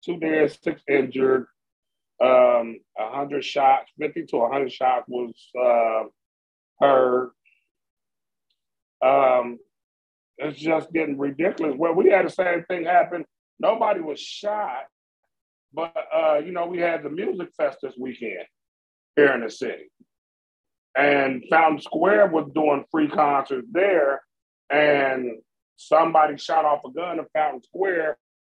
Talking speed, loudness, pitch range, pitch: 130 wpm, -22 LUFS, 125-165 Hz, 145 Hz